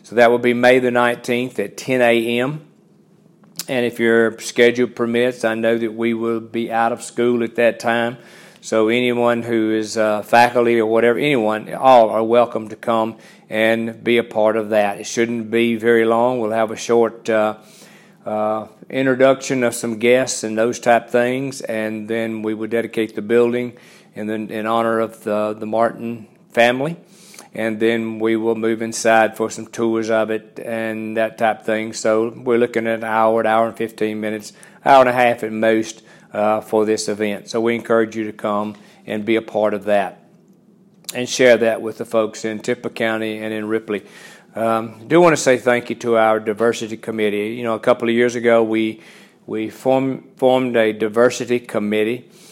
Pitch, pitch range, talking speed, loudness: 115 Hz, 110-120 Hz, 195 wpm, -18 LUFS